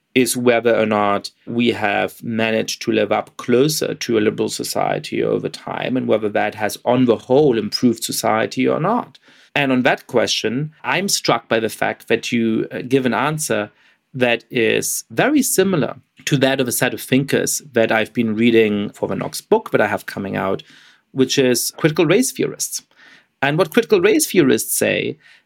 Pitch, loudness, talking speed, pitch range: 125 Hz, -18 LUFS, 180 wpm, 115-150 Hz